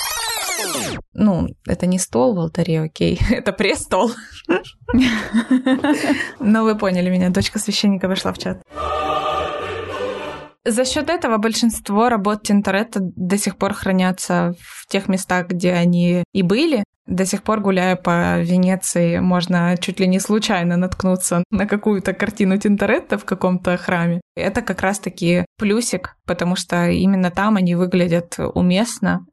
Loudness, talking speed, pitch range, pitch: -19 LUFS, 135 wpm, 180-215 Hz, 190 Hz